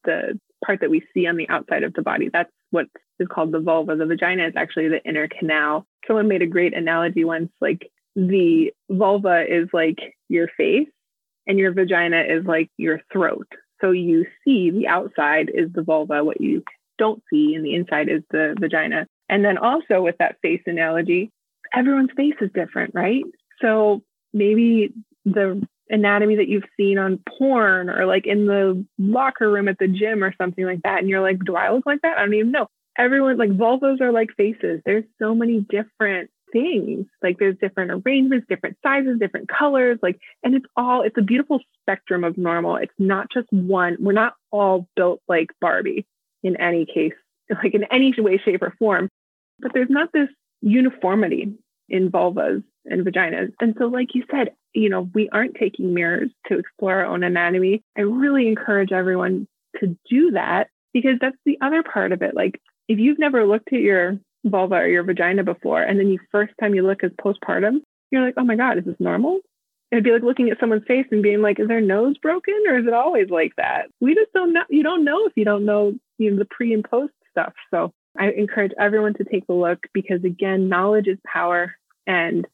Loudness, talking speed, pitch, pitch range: -20 LUFS, 200 wpm, 205 Hz, 185-250 Hz